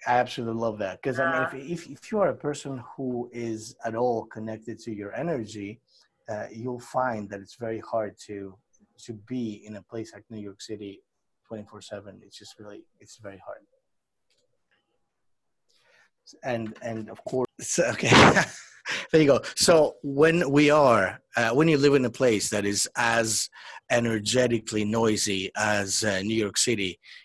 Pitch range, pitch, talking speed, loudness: 105-130 Hz, 115 Hz, 165 wpm, -25 LUFS